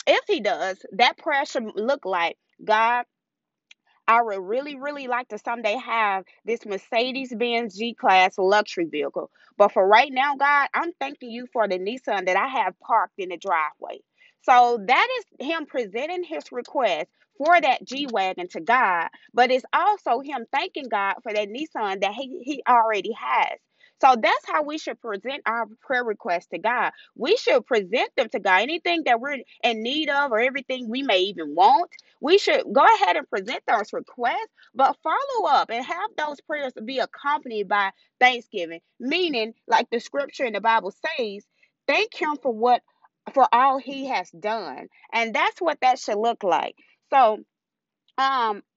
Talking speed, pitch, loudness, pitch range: 170 wpm, 245 Hz, -23 LUFS, 215-290 Hz